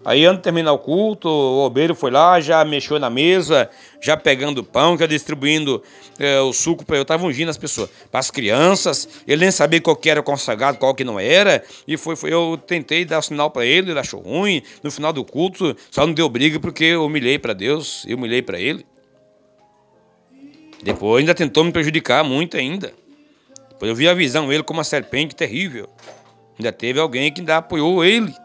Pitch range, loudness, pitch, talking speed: 145-170 Hz, -17 LUFS, 155 Hz, 205 wpm